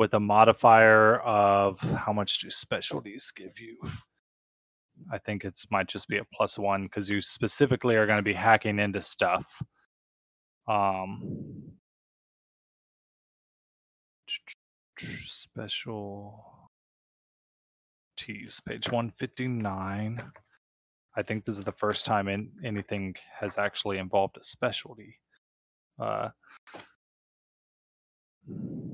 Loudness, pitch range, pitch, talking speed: -27 LUFS, 100-110 Hz, 105 Hz, 100 wpm